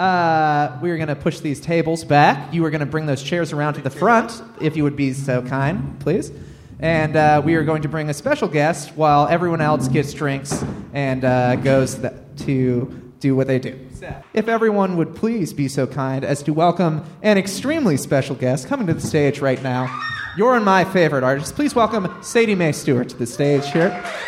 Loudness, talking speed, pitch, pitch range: -19 LUFS, 205 wpm, 150 Hz, 135-175 Hz